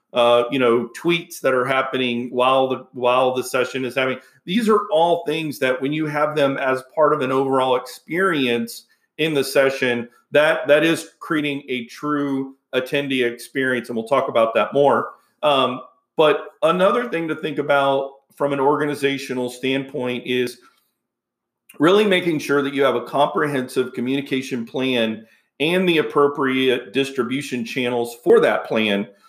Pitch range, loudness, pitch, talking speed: 125-150 Hz, -20 LUFS, 135 Hz, 155 wpm